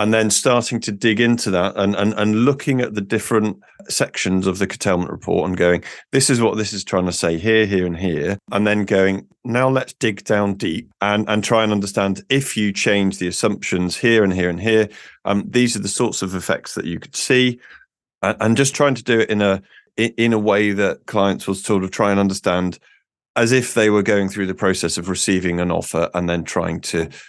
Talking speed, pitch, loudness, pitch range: 225 wpm, 105 Hz, -19 LUFS, 95-115 Hz